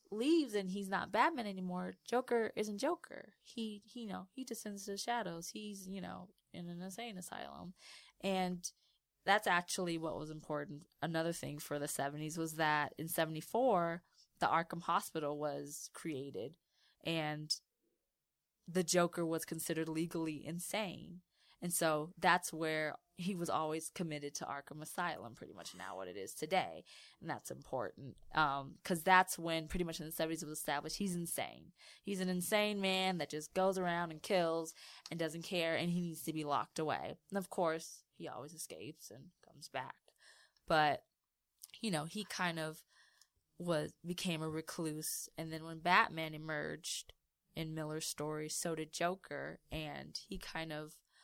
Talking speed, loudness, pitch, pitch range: 165 wpm, -39 LUFS, 170 Hz, 155-190 Hz